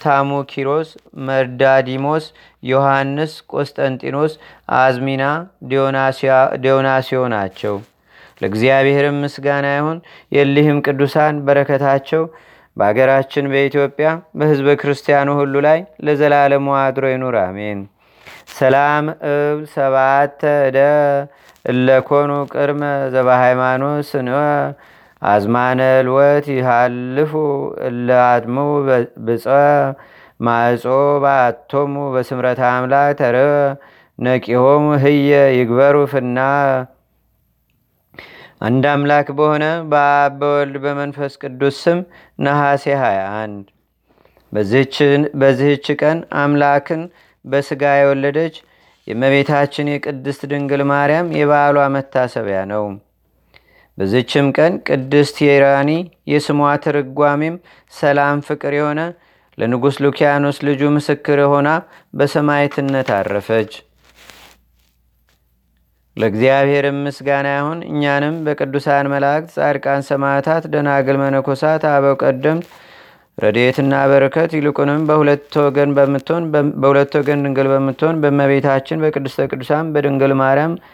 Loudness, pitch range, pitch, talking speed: -15 LUFS, 135-145 Hz, 140 Hz, 75 wpm